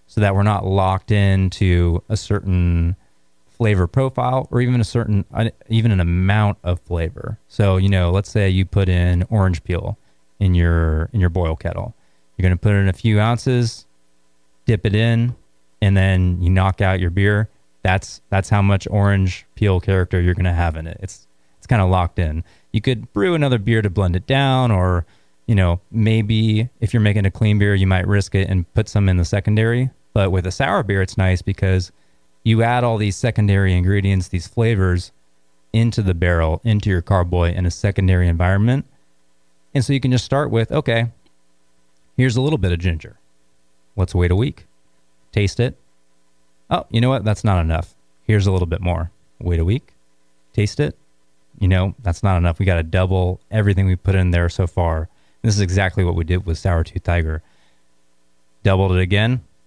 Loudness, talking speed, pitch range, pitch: -18 LUFS, 195 wpm, 85-105 Hz, 95 Hz